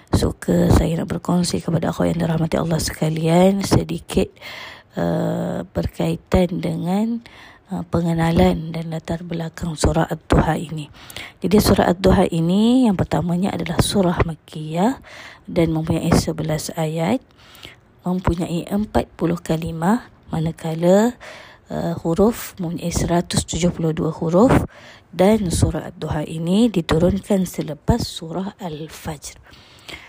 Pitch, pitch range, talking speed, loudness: 170 Hz, 160-185 Hz, 105 wpm, -20 LUFS